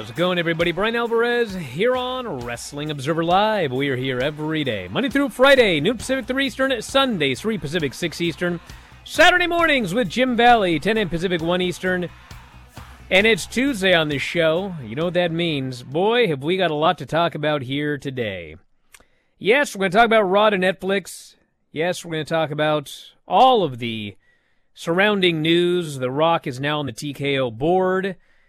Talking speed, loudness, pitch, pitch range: 185 wpm, -20 LUFS, 175 Hz, 150-220 Hz